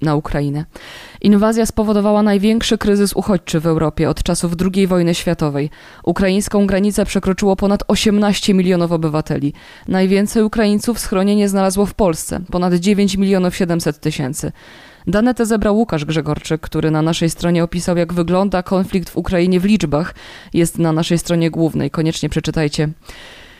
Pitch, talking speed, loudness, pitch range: 180 Hz, 140 wpm, -16 LUFS, 160-205 Hz